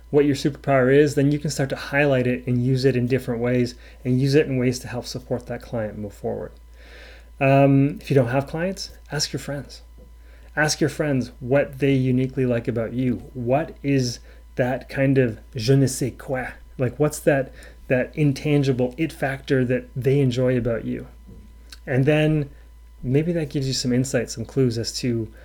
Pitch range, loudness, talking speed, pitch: 120-140 Hz, -22 LUFS, 190 wpm, 130 Hz